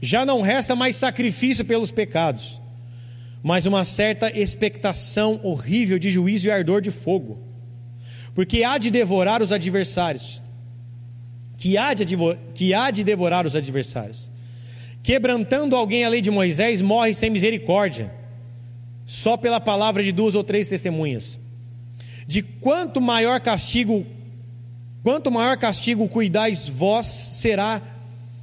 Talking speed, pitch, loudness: 130 wpm, 190 Hz, -21 LUFS